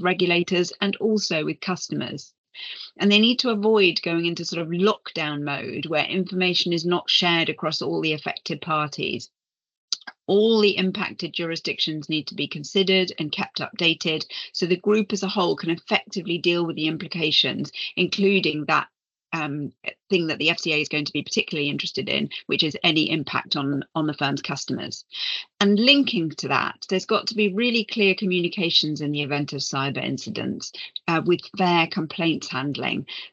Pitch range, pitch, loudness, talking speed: 155-190 Hz, 170 Hz, -23 LUFS, 170 wpm